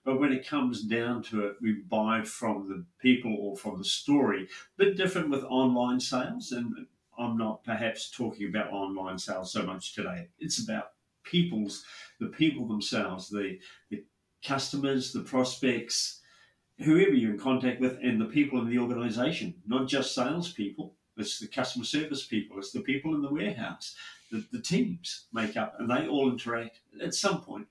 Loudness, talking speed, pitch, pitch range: -30 LUFS, 175 wpm, 125 Hz, 110-140 Hz